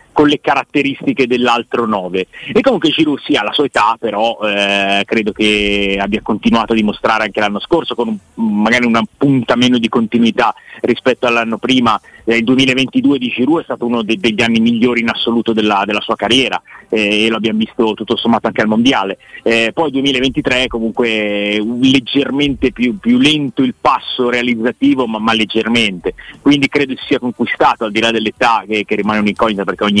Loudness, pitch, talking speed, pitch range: -14 LUFS, 115 Hz, 190 wpm, 110-130 Hz